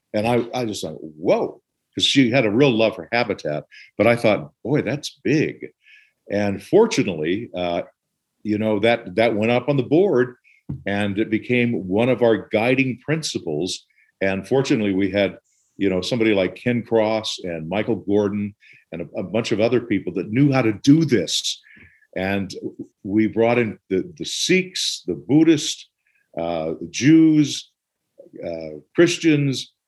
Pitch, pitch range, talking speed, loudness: 110 Hz, 100-130 Hz, 160 wpm, -20 LUFS